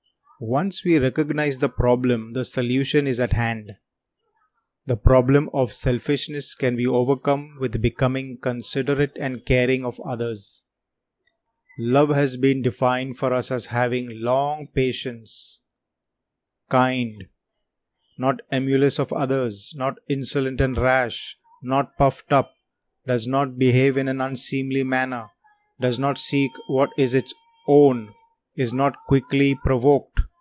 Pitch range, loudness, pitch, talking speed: 125-140 Hz, -22 LUFS, 130 Hz, 125 wpm